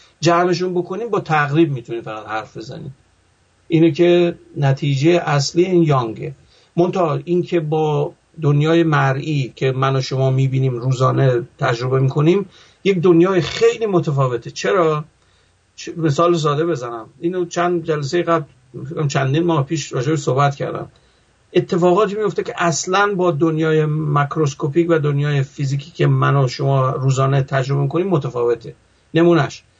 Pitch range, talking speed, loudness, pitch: 135-170 Hz, 135 wpm, -18 LUFS, 155 Hz